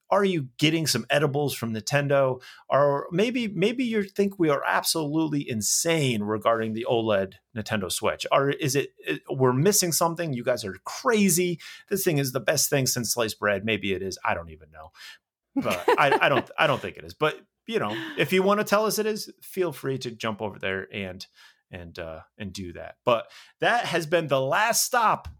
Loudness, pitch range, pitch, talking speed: -25 LUFS, 110-180 Hz, 140 Hz, 205 wpm